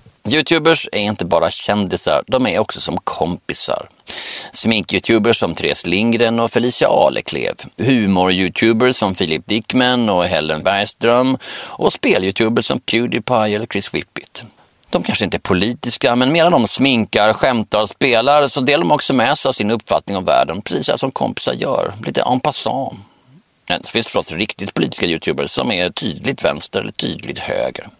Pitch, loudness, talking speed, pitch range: 115 Hz, -16 LUFS, 165 wpm, 100-125 Hz